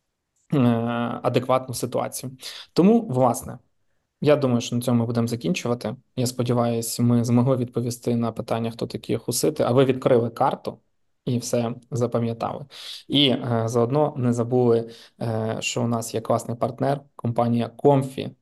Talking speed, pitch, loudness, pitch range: 135 wpm, 120 Hz, -23 LUFS, 115-130 Hz